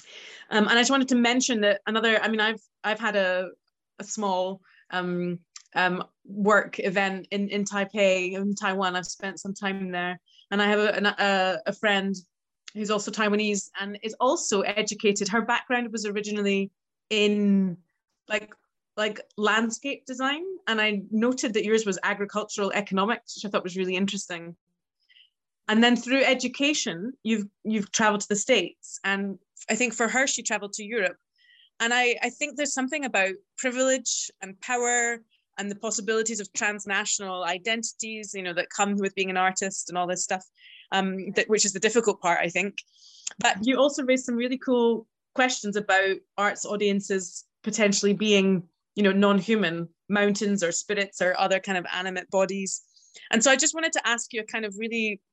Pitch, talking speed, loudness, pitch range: 205 Hz, 175 wpm, -25 LUFS, 195-230 Hz